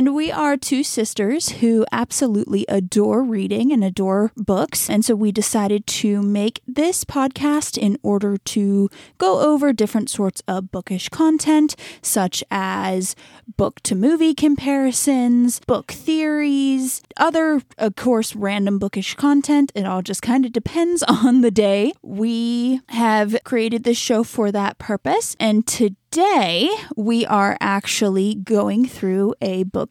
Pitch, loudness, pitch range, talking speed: 225 Hz, -19 LUFS, 205-275 Hz, 140 wpm